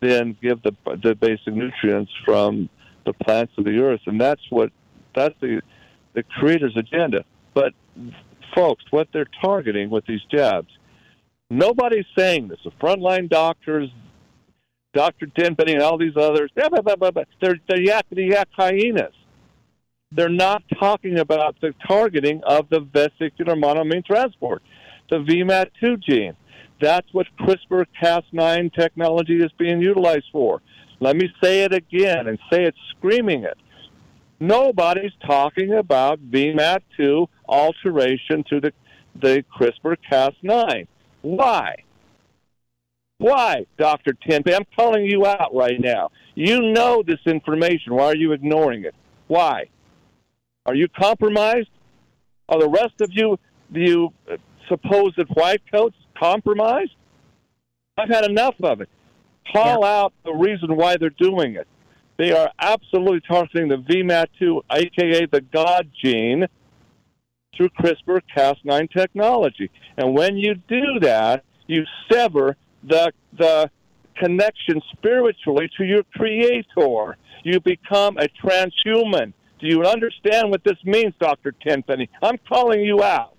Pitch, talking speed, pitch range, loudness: 170 Hz, 130 wpm, 145-200 Hz, -19 LUFS